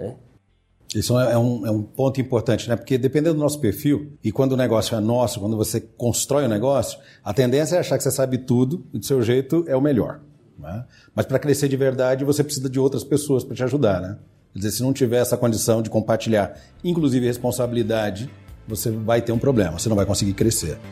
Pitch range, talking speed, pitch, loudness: 110-135 Hz, 220 wpm, 120 Hz, -21 LUFS